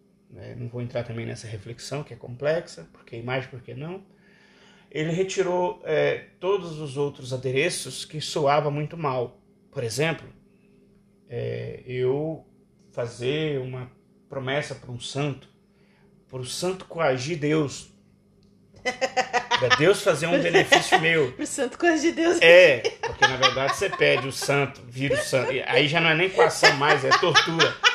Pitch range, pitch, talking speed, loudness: 130-195 Hz, 150 Hz, 150 wpm, -23 LUFS